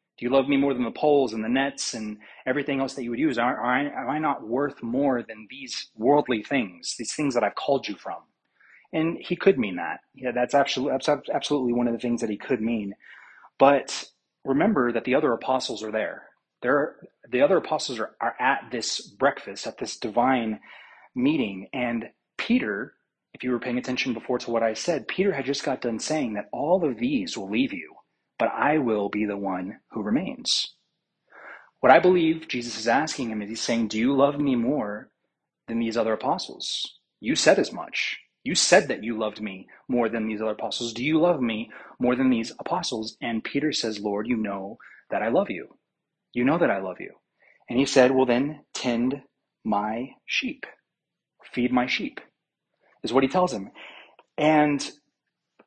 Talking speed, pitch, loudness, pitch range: 195 wpm, 125 Hz, -25 LUFS, 115-140 Hz